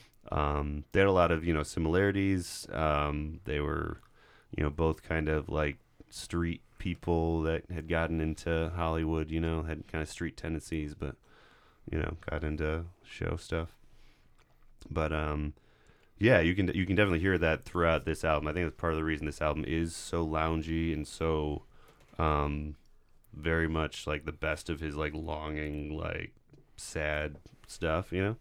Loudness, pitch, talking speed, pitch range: -32 LUFS, 80 Hz, 170 wpm, 75-85 Hz